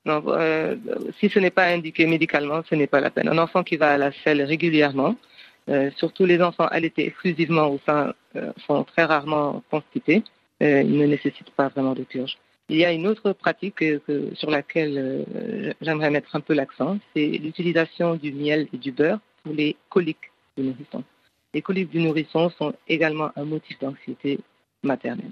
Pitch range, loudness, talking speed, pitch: 145-170 Hz, -23 LUFS, 185 wpm, 155 Hz